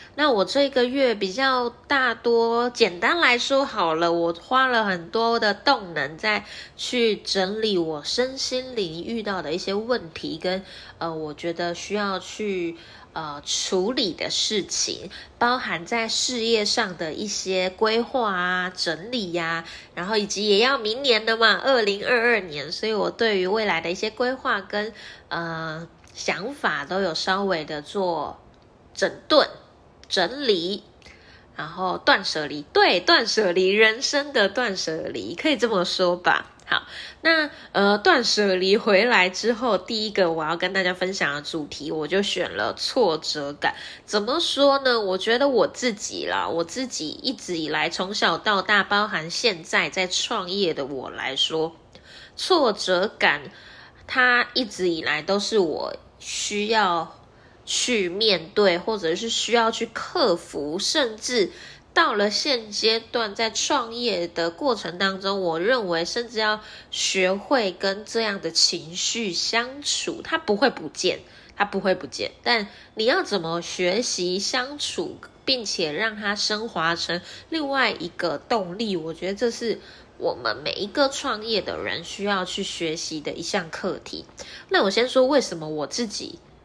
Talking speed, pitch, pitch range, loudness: 220 characters per minute, 205 Hz, 175-240 Hz, -23 LUFS